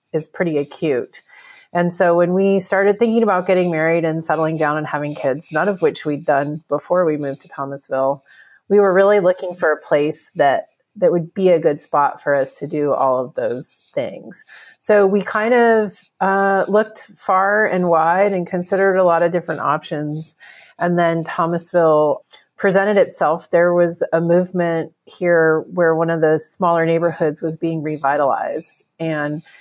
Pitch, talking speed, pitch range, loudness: 170 Hz, 175 wpm, 155-190 Hz, -17 LUFS